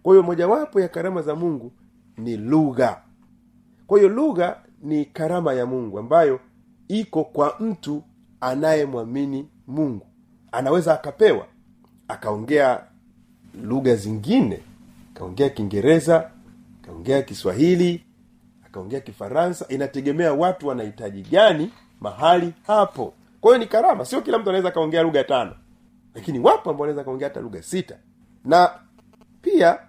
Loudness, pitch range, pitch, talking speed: -21 LUFS, 140-220 Hz, 165 Hz, 120 wpm